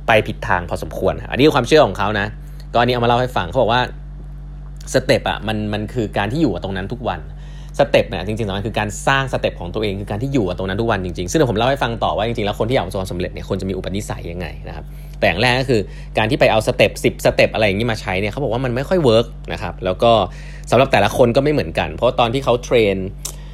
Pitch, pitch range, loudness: 115 Hz, 100-140 Hz, -18 LUFS